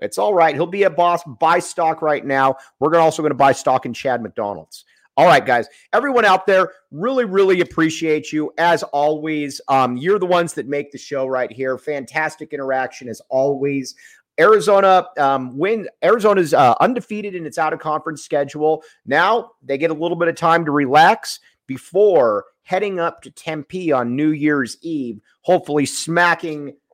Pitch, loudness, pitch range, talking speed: 155 Hz, -17 LUFS, 140-175 Hz, 170 wpm